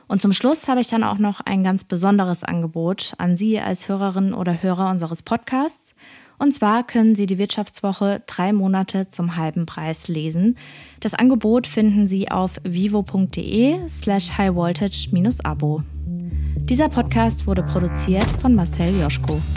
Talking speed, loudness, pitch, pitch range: 150 wpm, -20 LUFS, 195 Hz, 175-215 Hz